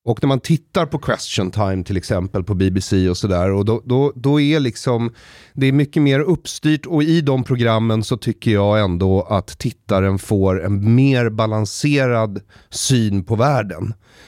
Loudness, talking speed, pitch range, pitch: -18 LUFS, 175 wpm, 100-135 Hz, 115 Hz